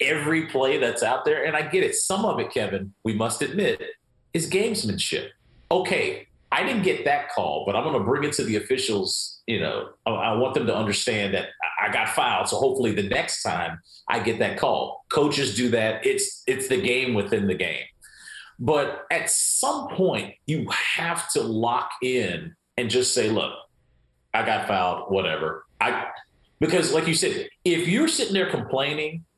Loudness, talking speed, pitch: -24 LUFS, 185 wpm, 155 Hz